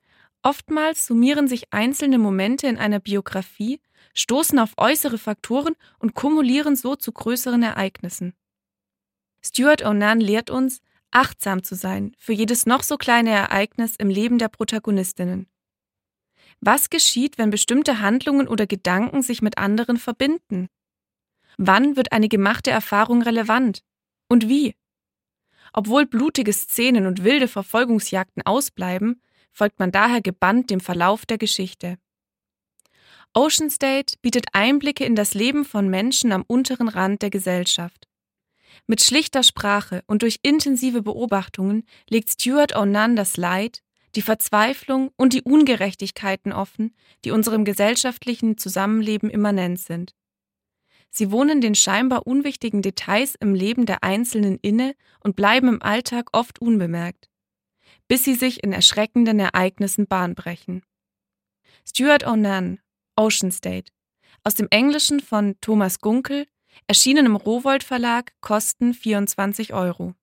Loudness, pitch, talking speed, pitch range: -20 LUFS, 220 Hz, 125 wpm, 195-250 Hz